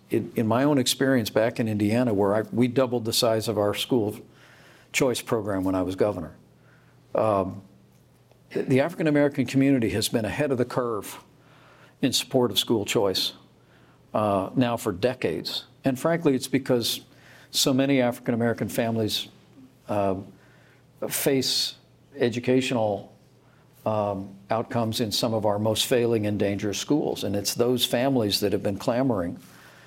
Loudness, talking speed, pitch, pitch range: -25 LUFS, 145 wpm, 120 Hz, 105-130 Hz